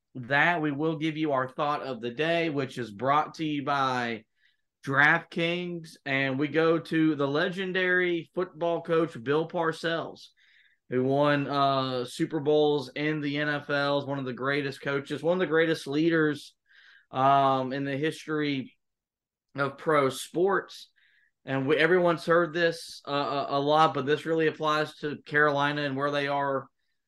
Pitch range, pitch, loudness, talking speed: 140-160 Hz, 150 Hz, -27 LUFS, 155 wpm